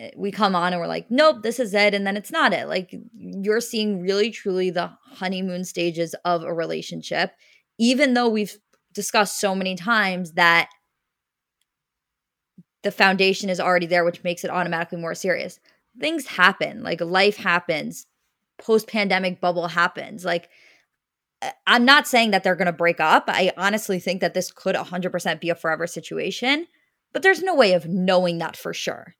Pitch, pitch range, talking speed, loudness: 185 Hz, 175-215 Hz, 175 wpm, -21 LUFS